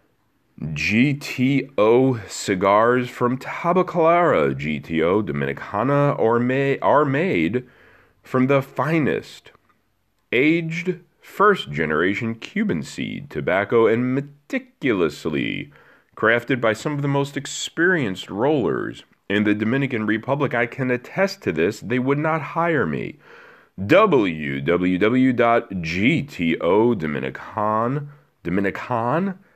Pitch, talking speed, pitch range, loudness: 130 Hz, 90 wpm, 105-145 Hz, -21 LUFS